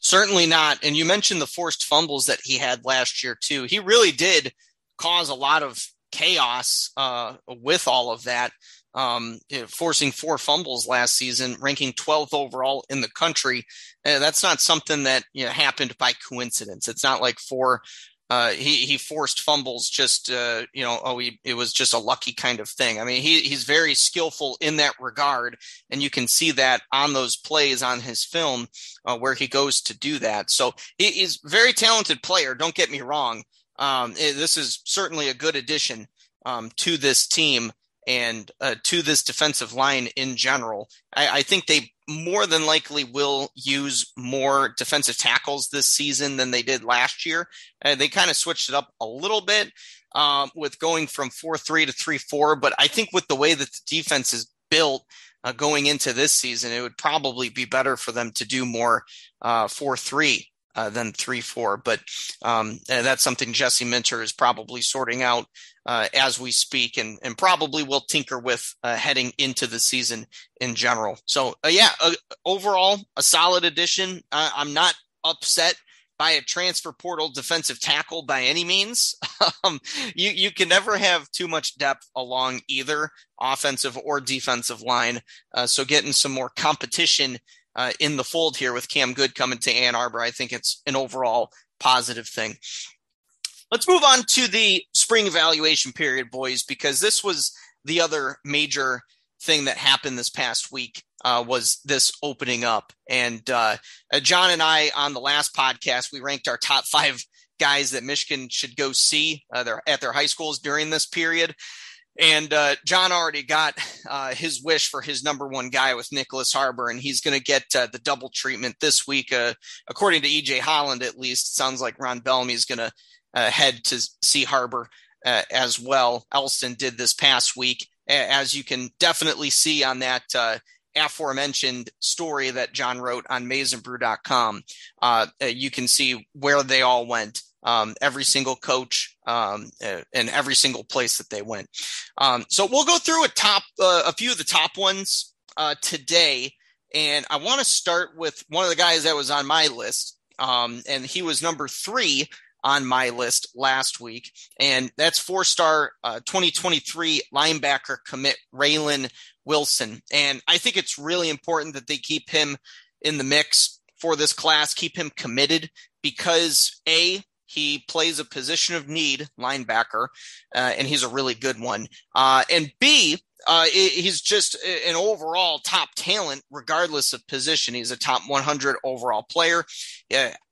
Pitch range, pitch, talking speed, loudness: 130-160 Hz, 140 Hz, 180 wpm, -21 LUFS